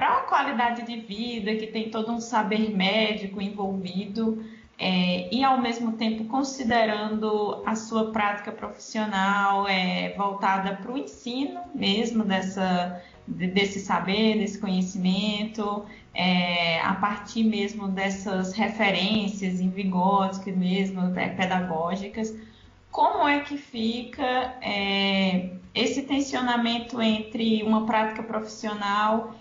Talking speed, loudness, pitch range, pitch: 115 wpm, -26 LUFS, 195-225 Hz, 210 Hz